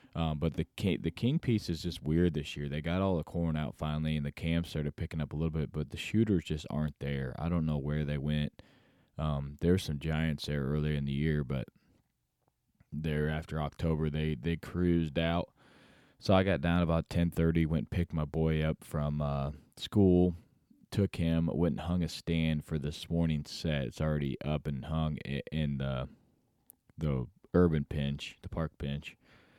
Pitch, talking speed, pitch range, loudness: 80 Hz, 195 wpm, 75-85 Hz, -33 LUFS